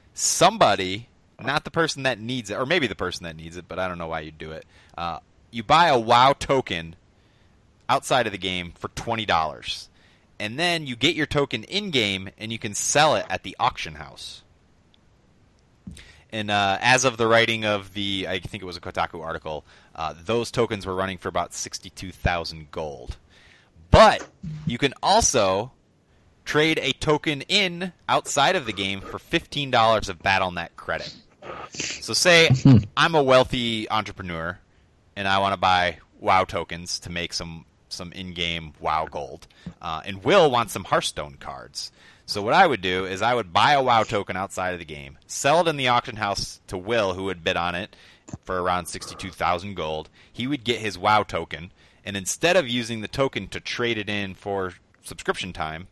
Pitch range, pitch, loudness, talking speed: 90-120 Hz, 100 Hz, -23 LUFS, 185 wpm